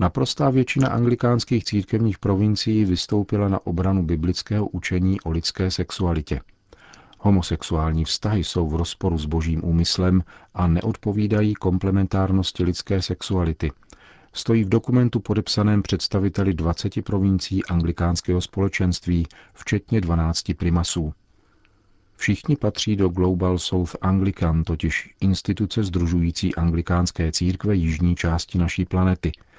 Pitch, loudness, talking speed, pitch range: 95 Hz, -22 LUFS, 105 wpm, 85-105 Hz